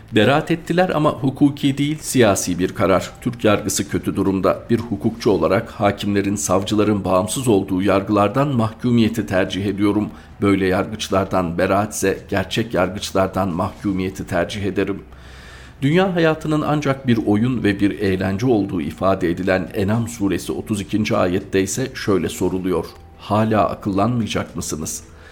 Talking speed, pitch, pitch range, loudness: 125 wpm, 100 Hz, 95-115 Hz, -19 LUFS